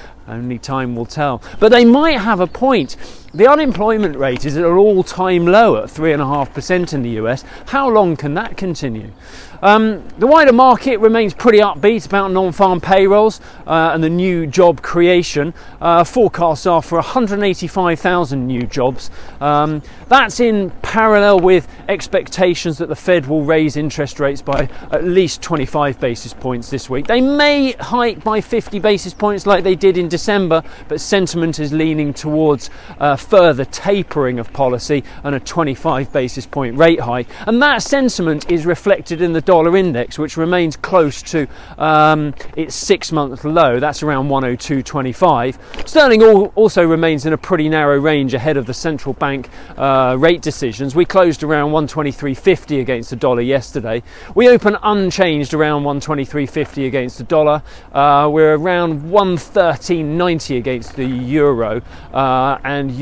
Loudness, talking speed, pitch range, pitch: -14 LUFS, 155 wpm, 140-190 Hz, 160 Hz